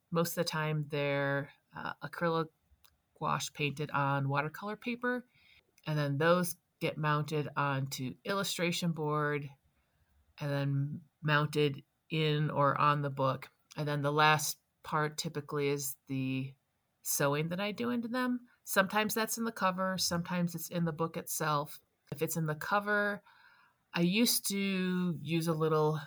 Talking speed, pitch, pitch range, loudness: 145 wpm, 155 Hz, 145-180 Hz, -33 LUFS